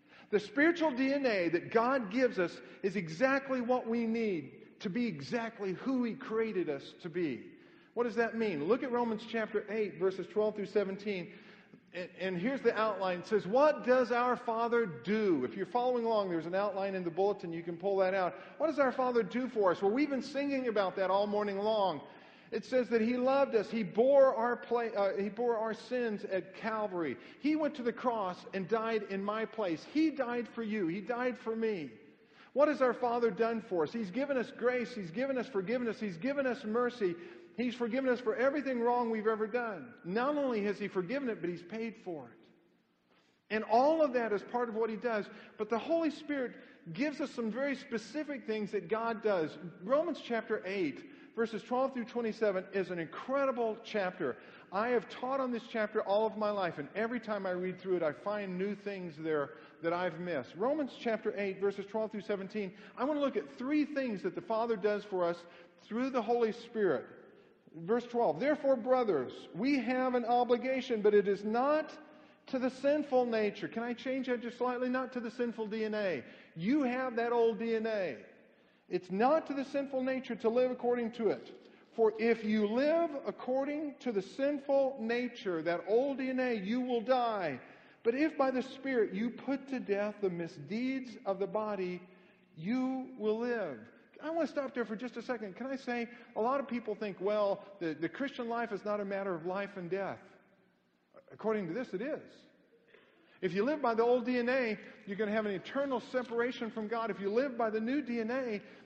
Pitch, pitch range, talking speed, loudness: 230 Hz, 205-255 Hz, 200 wpm, -34 LUFS